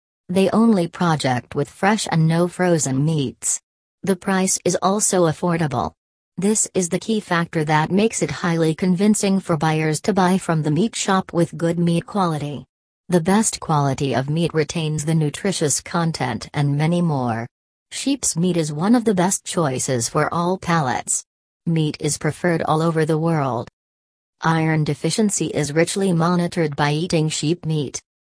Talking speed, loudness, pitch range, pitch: 160 wpm, -20 LUFS, 150-180 Hz, 165 Hz